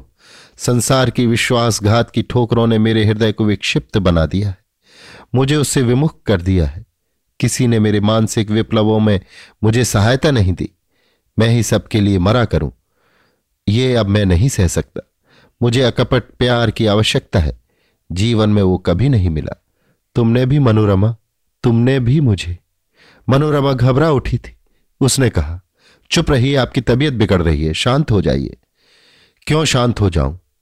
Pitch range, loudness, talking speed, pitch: 100-125 Hz, -15 LUFS, 155 wpm, 110 Hz